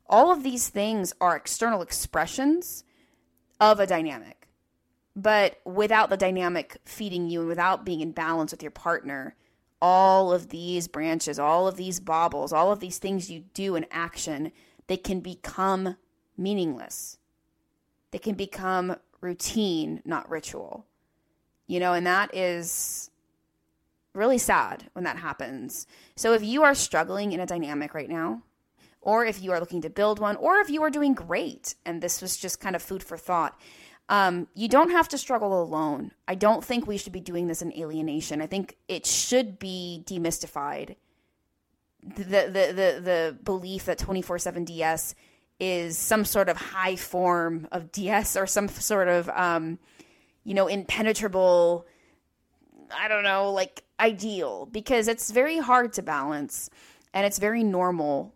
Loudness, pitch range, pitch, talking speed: -26 LUFS, 170-210 Hz, 185 Hz, 160 wpm